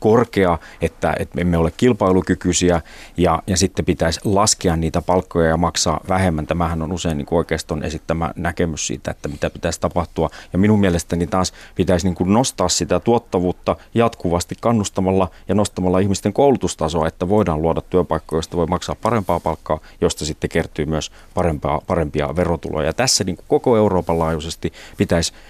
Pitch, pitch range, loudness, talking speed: 85 Hz, 80-95 Hz, -19 LUFS, 160 wpm